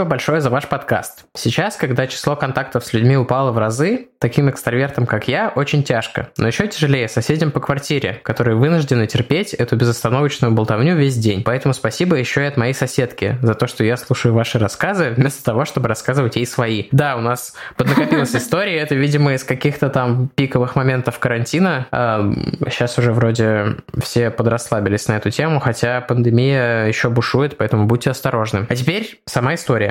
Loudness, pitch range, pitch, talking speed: -17 LUFS, 120-145 Hz, 125 Hz, 170 wpm